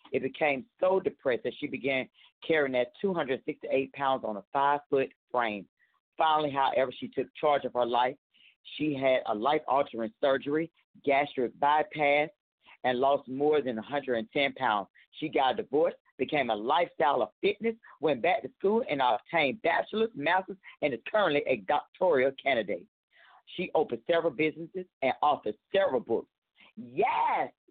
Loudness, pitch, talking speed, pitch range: -29 LUFS, 145 Hz, 150 wpm, 130-160 Hz